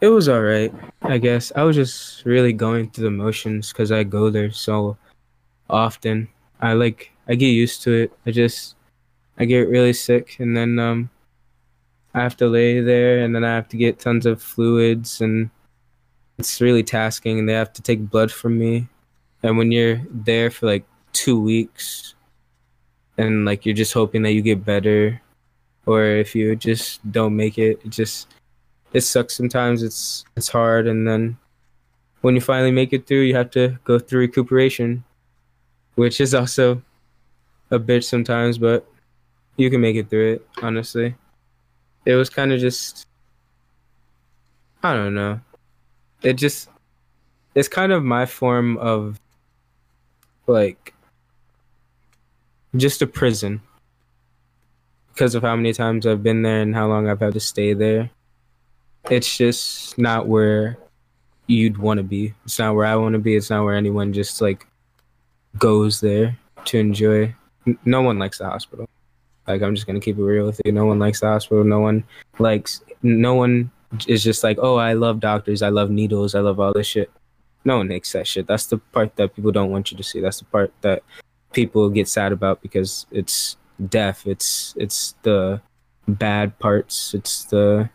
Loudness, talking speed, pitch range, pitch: -19 LUFS, 175 wpm, 110-120 Hz, 115 Hz